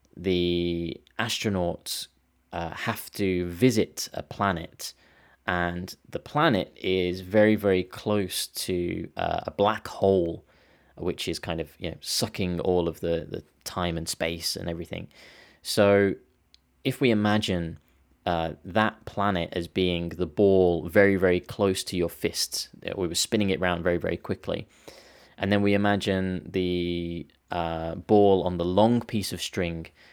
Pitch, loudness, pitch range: 90 Hz, -26 LUFS, 85-100 Hz